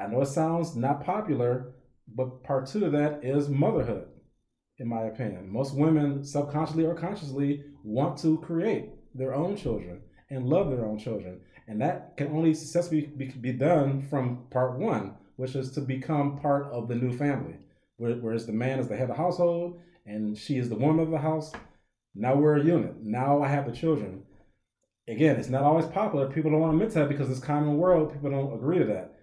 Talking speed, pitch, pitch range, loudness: 200 wpm, 140 Hz, 125-155 Hz, -28 LUFS